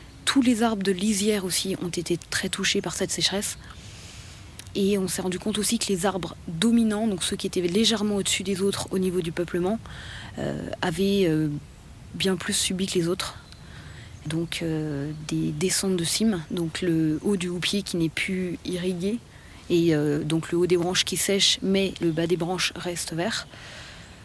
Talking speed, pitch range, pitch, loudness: 185 wpm, 160-195 Hz, 180 Hz, -25 LUFS